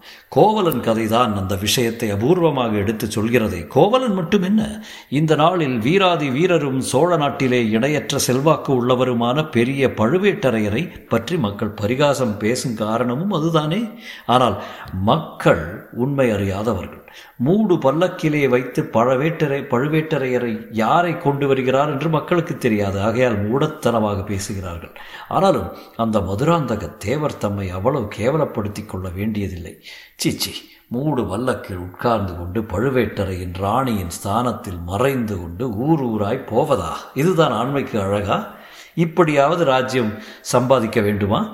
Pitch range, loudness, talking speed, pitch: 105-150 Hz, -19 LUFS, 105 wpm, 125 Hz